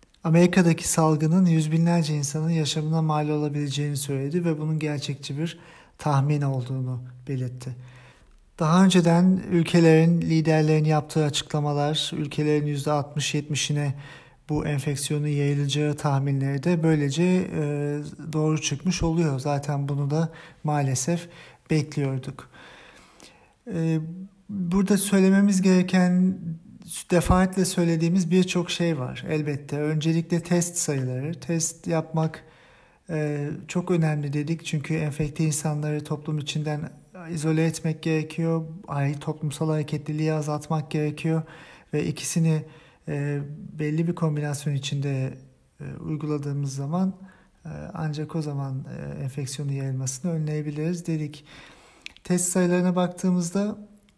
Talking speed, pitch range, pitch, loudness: 100 wpm, 145-170 Hz, 155 Hz, -25 LUFS